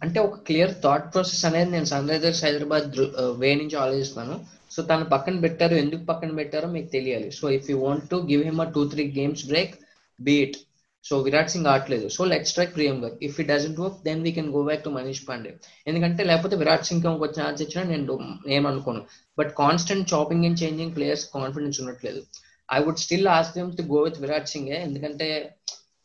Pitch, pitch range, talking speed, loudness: 150 Hz, 140-165 Hz, 185 wpm, -24 LUFS